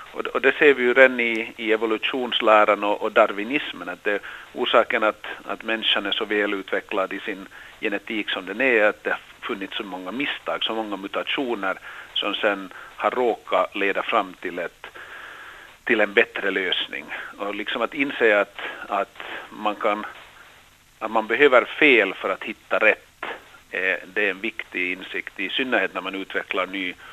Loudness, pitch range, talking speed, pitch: -22 LUFS, 100-115 Hz, 170 wpm, 110 Hz